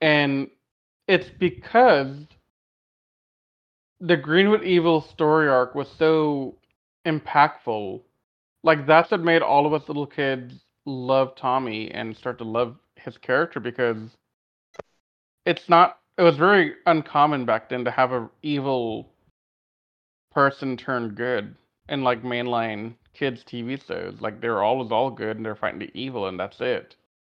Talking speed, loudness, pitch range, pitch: 140 wpm, -22 LUFS, 120-155 Hz, 135 Hz